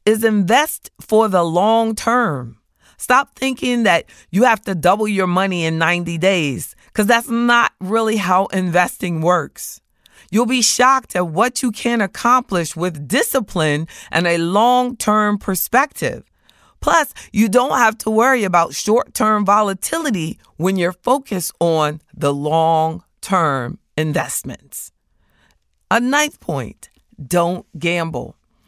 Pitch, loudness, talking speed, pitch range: 195 Hz, -17 LUFS, 130 wpm, 170-235 Hz